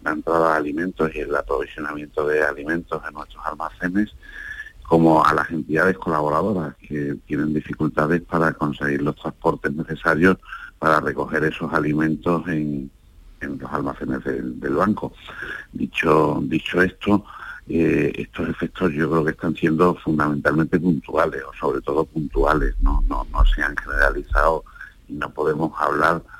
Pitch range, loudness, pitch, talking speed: 75-85 Hz, -22 LUFS, 80 Hz, 145 wpm